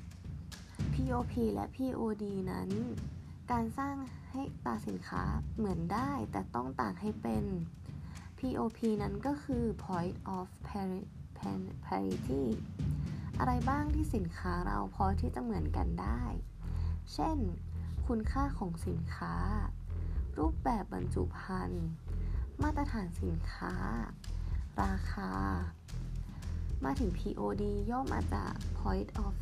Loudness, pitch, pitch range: -37 LUFS, 90 Hz, 85-110 Hz